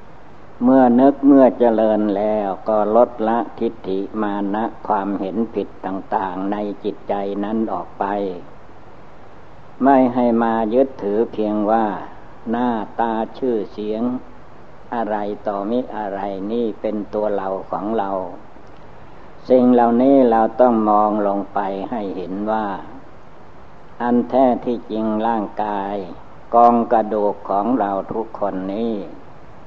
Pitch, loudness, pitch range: 110 Hz, -19 LUFS, 100-120 Hz